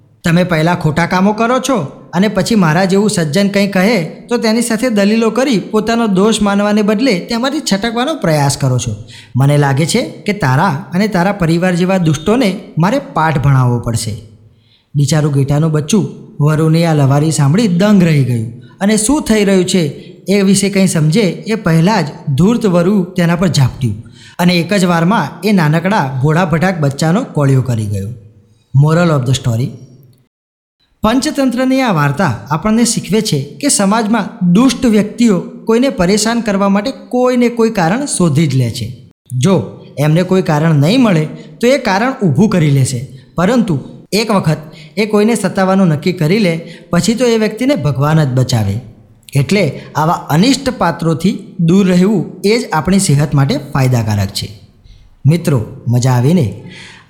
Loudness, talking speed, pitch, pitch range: -12 LUFS, 155 wpm, 175 Hz, 140-210 Hz